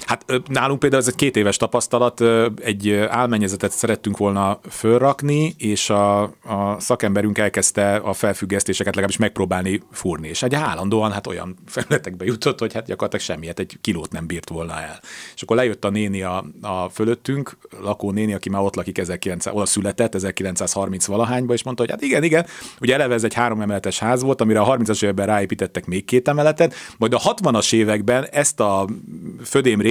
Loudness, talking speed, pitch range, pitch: -20 LUFS, 180 wpm, 100-120 Hz, 105 Hz